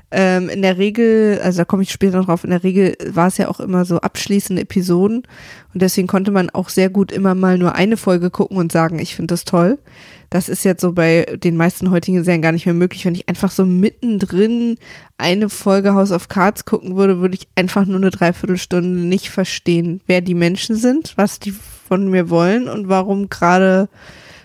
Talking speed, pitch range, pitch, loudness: 210 wpm, 180-200 Hz, 185 Hz, -16 LUFS